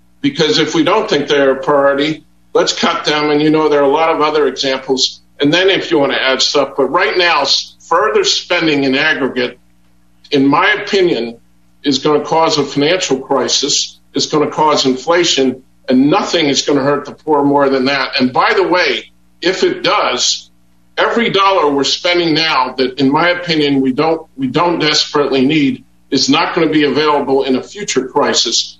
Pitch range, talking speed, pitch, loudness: 130-155 Hz, 195 wpm, 145 Hz, -13 LUFS